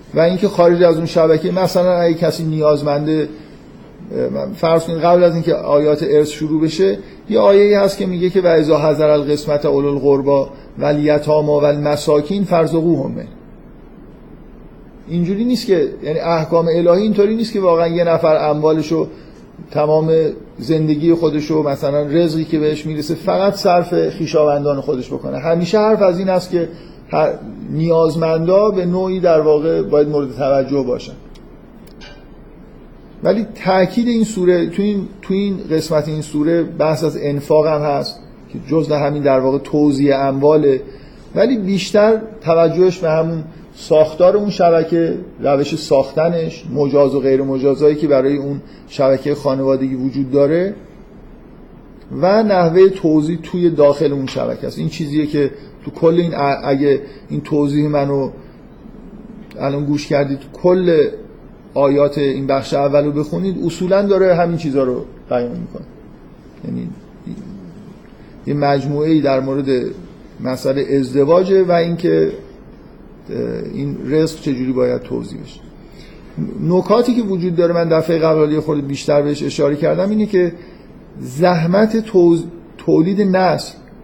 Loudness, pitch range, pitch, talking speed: -15 LUFS, 145-180 Hz, 160 Hz, 140 wpm